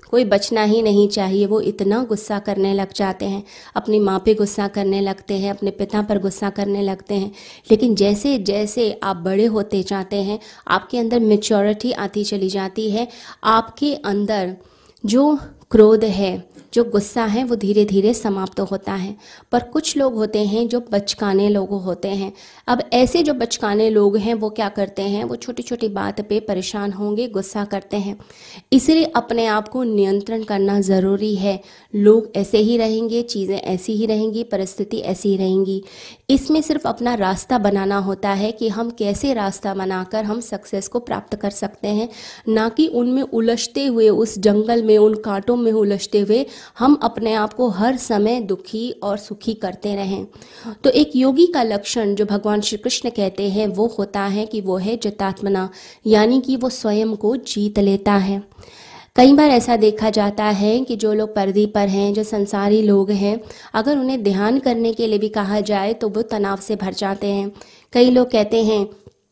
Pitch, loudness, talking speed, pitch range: 210 Hz, -18 LUFS, 185 wpm, 200-230 Hz